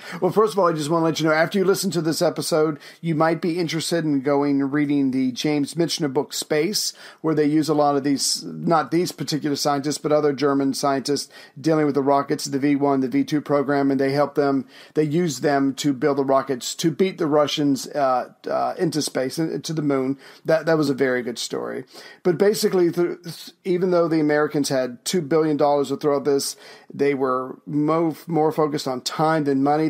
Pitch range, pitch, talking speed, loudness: 140-165 Hz, 150 Hz, 215 wpm, -21 LUFS